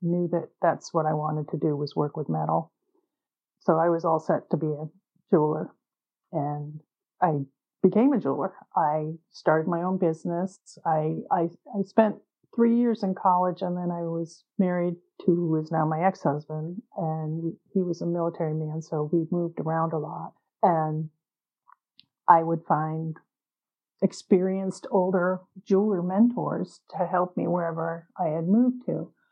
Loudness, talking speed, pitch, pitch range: -27 LUFS, 160 wpm, 170 Hz, 155-185 Hz